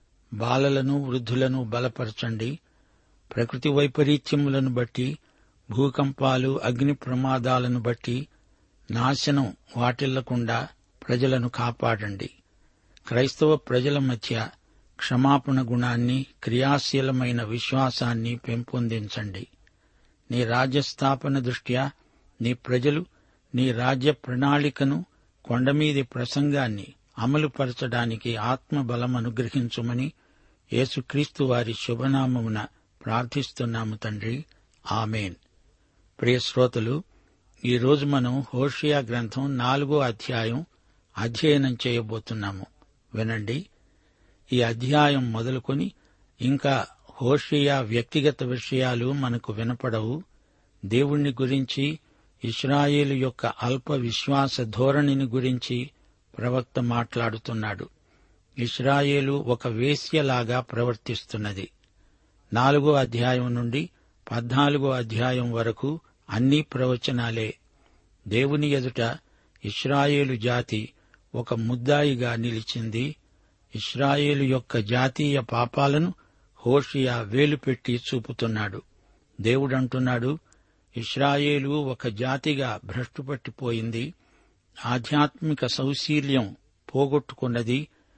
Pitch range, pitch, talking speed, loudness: 115-140 Hz, 125 Hz, 70 wpm, -26 LUFS